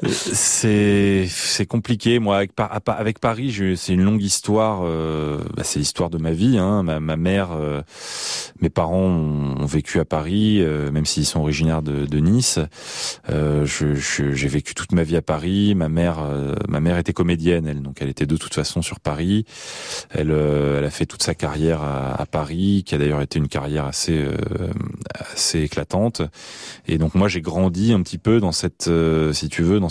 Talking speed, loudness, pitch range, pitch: 200 wpm, -20 LUFS, 75-95 Hz, 80 Hz